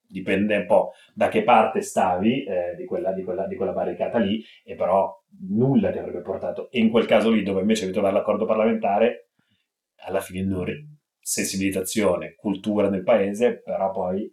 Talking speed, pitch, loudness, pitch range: 180 wpm, 100 Hz, -23 LUFS, 95-115 Hz